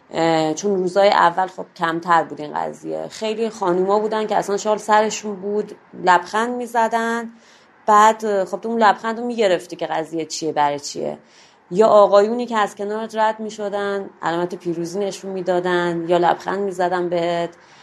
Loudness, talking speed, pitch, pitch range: -19 LUFS, 170 wpm, 200 Hz, 170-215 Hz